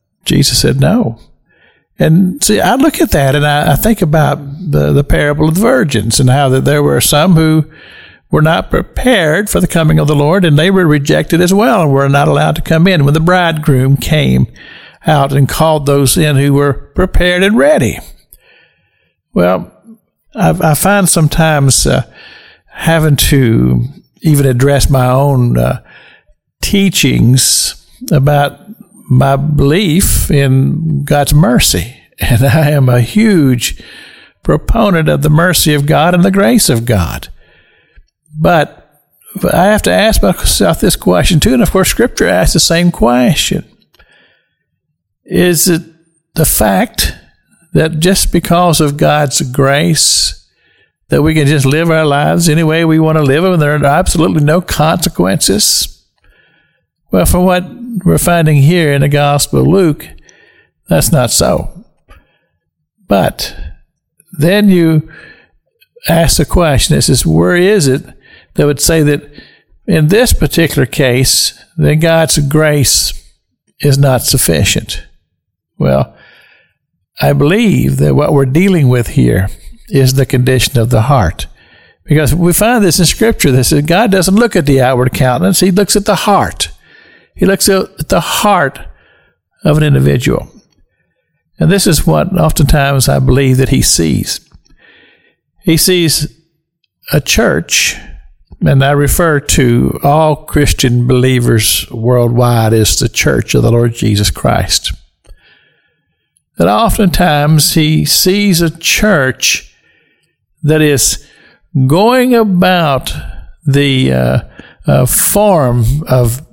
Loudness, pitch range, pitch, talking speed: -10 LUFS, 135-180 Hz, 150 Hz, 140 wpm